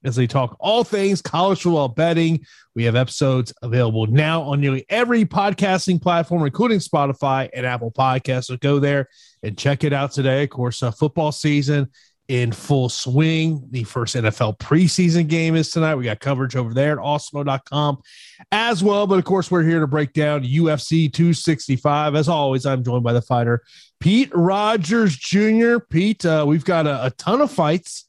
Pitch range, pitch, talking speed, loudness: 130-170 Hz, 145 Hz, 180 wpm, -19 LUFS